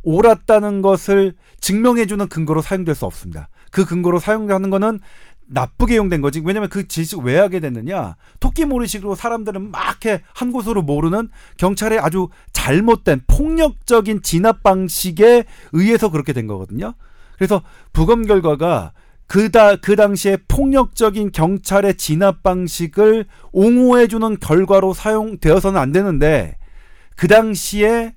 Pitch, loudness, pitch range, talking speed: 195 Hz, -16 LUFS, 170-220 Hz, 315 characters per minute